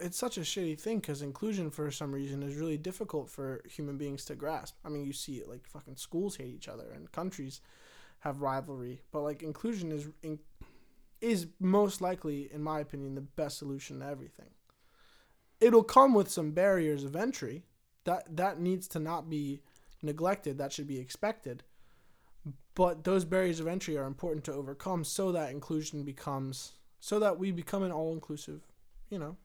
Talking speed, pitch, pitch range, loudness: 180 wpm, 155 Hz, 140-185 Hz, -34 LUFS